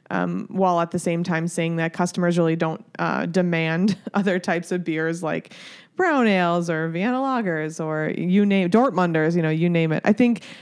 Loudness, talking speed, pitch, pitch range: -22 LUFS, 190 wpm, 175 Hz, 165-195 Hz